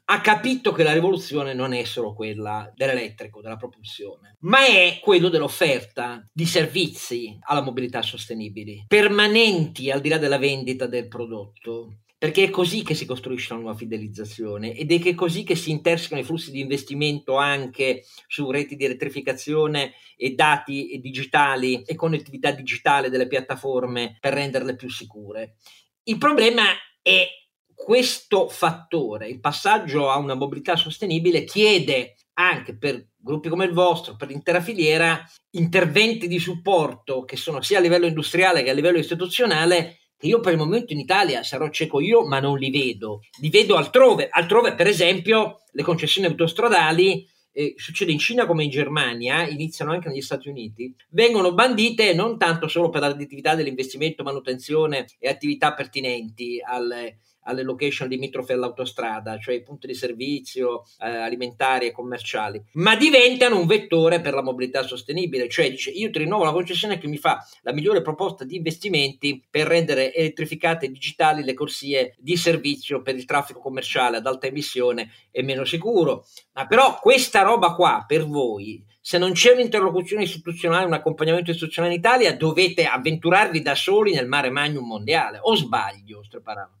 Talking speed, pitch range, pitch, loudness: 160 wpm, 130-175 Hz, 145 Hz, -21 LUFS